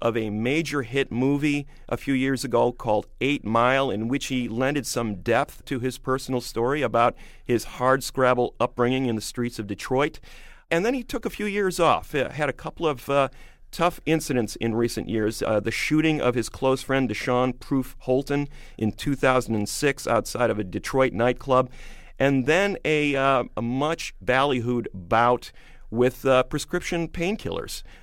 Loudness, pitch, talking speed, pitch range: -24 LUFS, 130 Hz, 170 wpm, 120-140 Hz